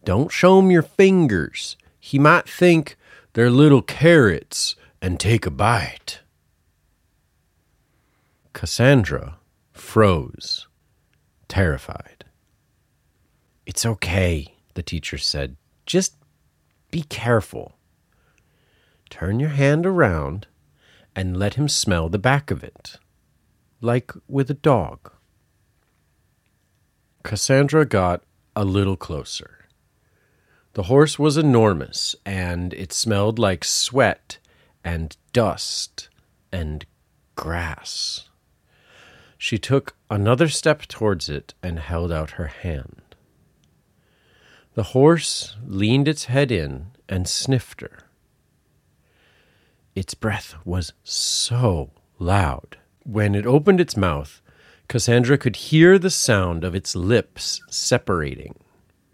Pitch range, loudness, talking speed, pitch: 85-135 Hz, -20 LUFS, 100 wpm, 100 Hz